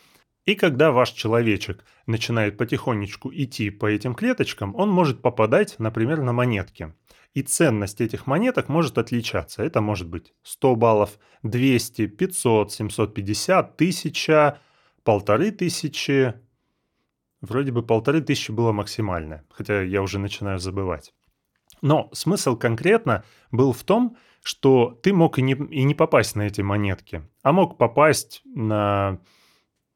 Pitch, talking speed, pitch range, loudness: 120 Hz, 125 wpm, 105-140 Hz, -22 LUFS